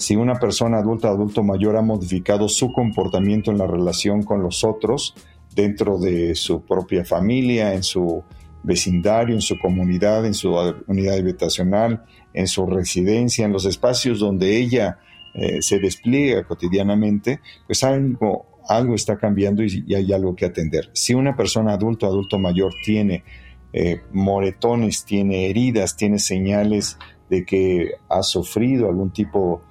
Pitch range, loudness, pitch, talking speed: 95-110 Hz, -20 LUFS, 100 Hz, 155 wpm